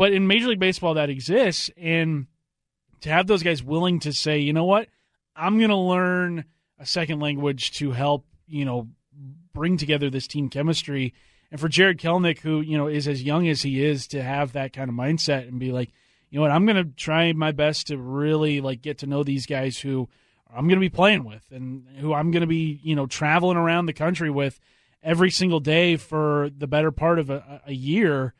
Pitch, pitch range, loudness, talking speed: 150 Hz, 140-165 Hz, -23 LUFS, 220 wpm